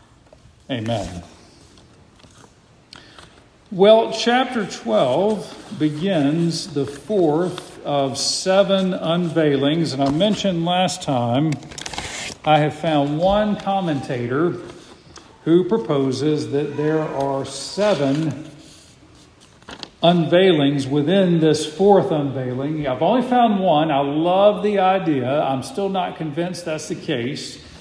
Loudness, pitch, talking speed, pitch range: -19 LUFS, 155 Hz, 100 wpm, 140-190 Hz